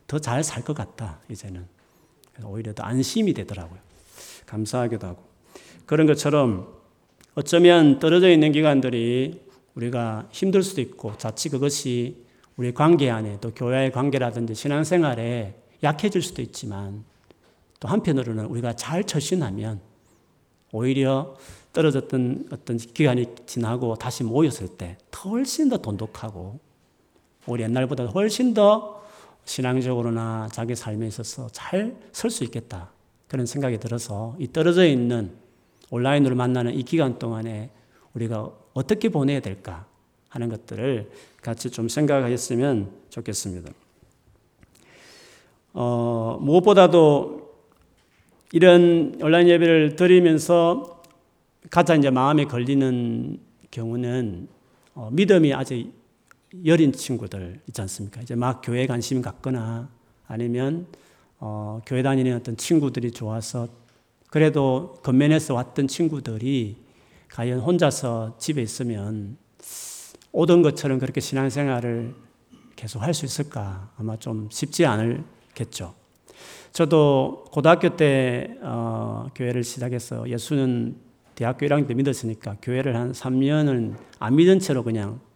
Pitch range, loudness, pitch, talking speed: 115-150 Hz, -22 LUFS, 125 Hz, 275 characters per minute